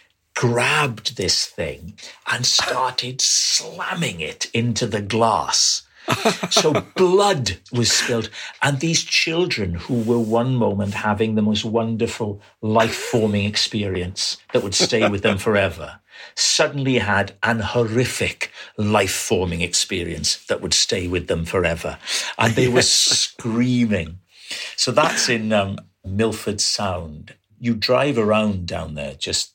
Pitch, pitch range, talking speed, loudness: 110 Hz, 100-120 Hz, 130 wpm, -19 LUFS